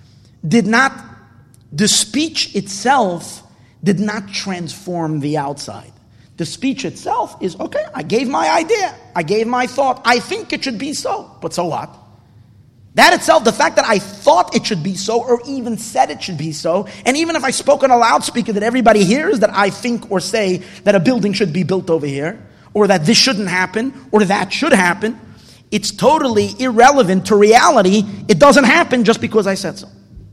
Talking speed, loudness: 190 wpm, -15 LUFS